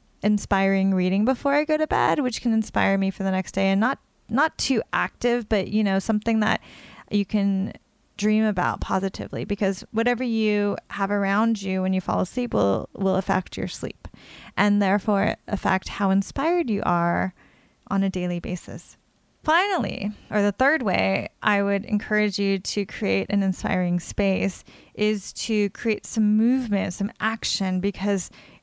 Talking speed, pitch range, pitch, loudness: 165 wpm, 195-220 Hz, 205 Hz, -24 LUFS